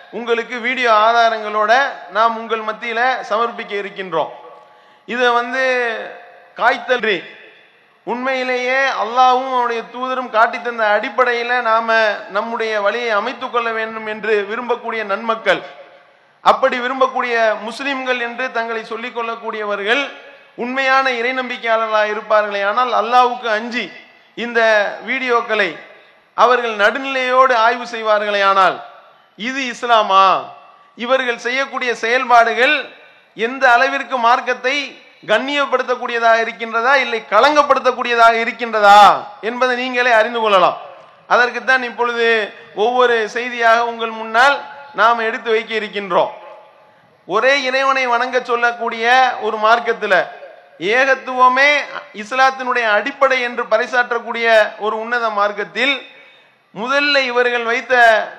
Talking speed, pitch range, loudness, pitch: 95 wpm, 220-255 Hz, -15 LUFS, 235 Hz